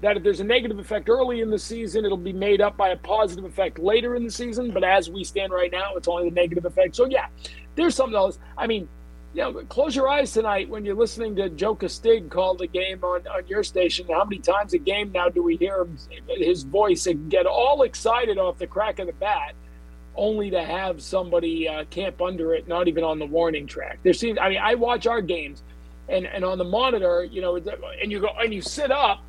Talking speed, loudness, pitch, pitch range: 240 wpm, -23 LUFS, 190 Hz, 175-225 Hz